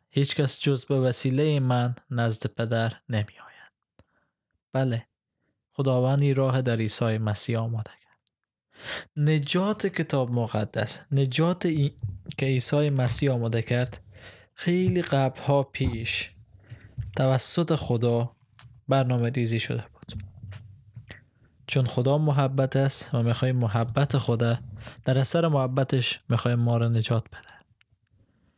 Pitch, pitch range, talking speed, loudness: 125 Hz, 115-140 Hz, 115 wpm, -26 LUFS